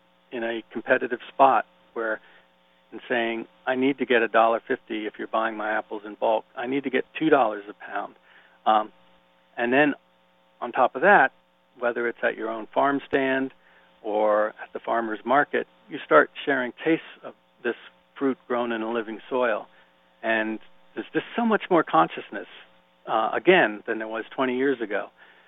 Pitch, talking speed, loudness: 110 Hz, 175 wpm, -24 LUFS